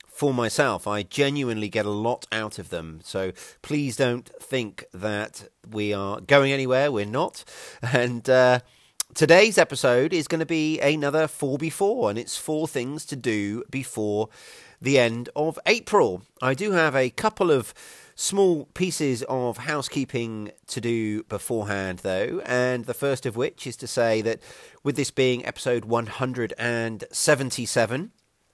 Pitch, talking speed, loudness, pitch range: 125 Hz, 155 wpm, -24 LUFS, 110-145 Hz